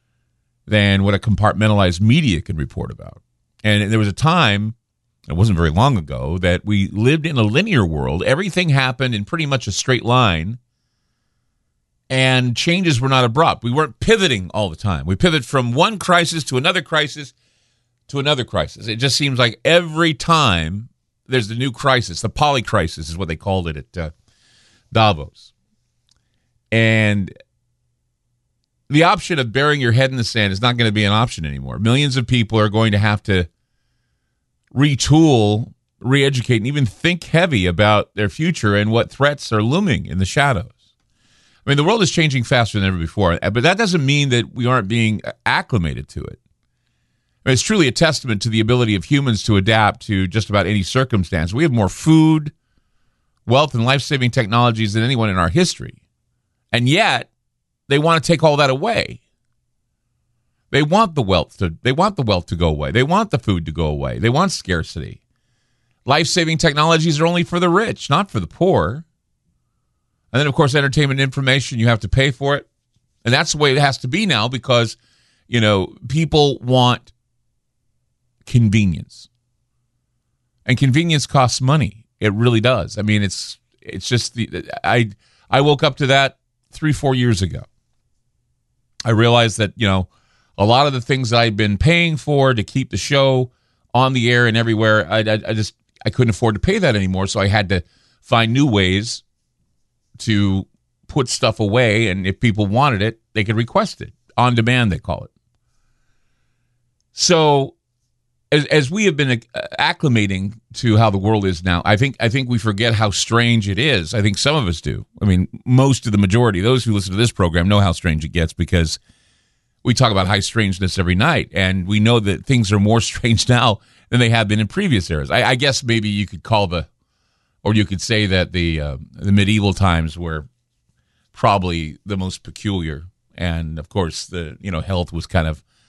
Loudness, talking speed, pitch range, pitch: -17 LUFS, 190 wpm, 100-130 Hz, 115 Hz